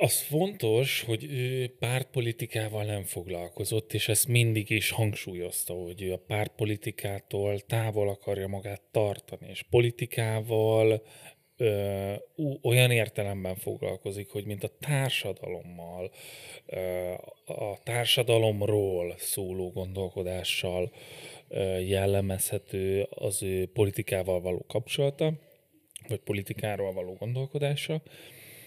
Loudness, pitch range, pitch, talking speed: -30 LUFS, 95-120 Hz, 105 Hz, 95 wpm